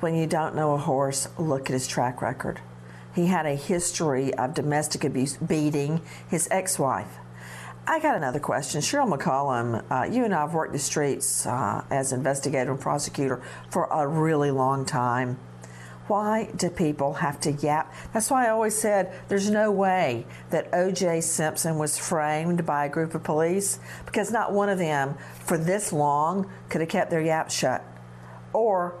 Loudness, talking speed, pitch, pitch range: -26 LUFS, 175 wpm, 155 Hz, 135-175 Hz